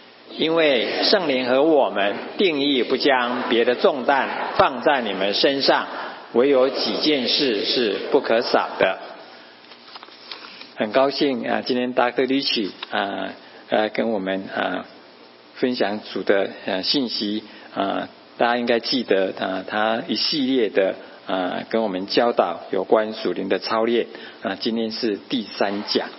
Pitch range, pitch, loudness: 90-120 Hz, 110 Hz, -21 LUFS